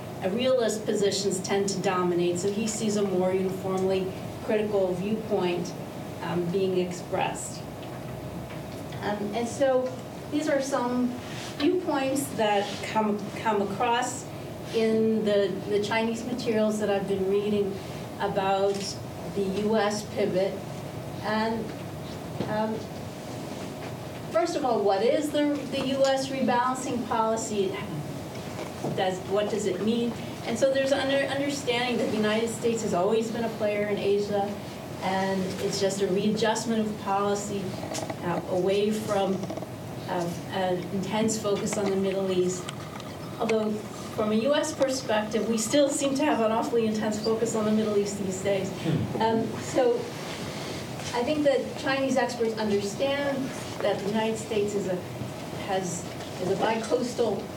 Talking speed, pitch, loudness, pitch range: 135 wpm, 210 Hz, -28 LUFS, 190-230 Hz